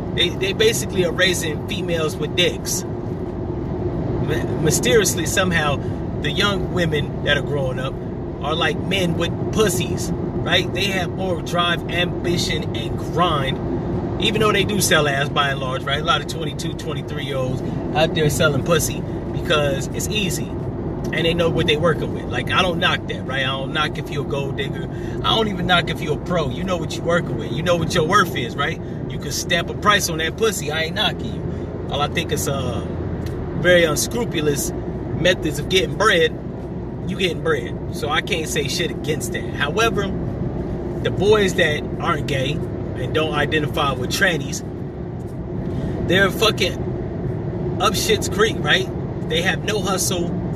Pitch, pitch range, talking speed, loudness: 155 Hz, 135-170 Hz, 180 wpm, -20 LUFS